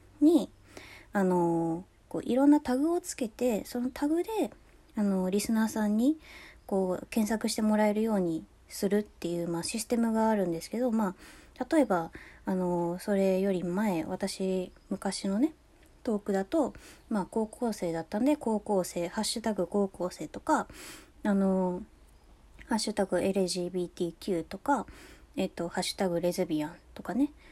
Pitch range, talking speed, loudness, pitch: 180-230 Hz, 305 characters per minute, -30 LUFS, 200 Hz